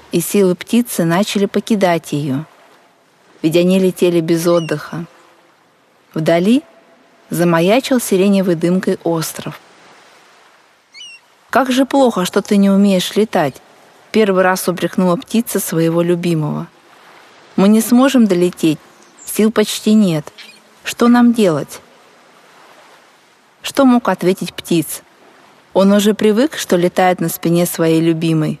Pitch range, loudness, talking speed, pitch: 170-210 Hz, -14 LUFS, 110 wpm, 185 Hz